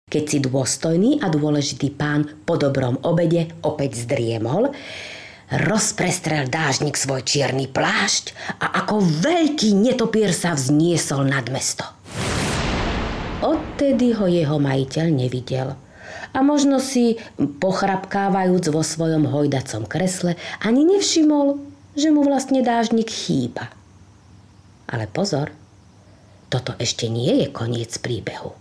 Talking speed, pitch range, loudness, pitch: 110 wpm, 130-200 Hz, -20 LUFS, 155 Hz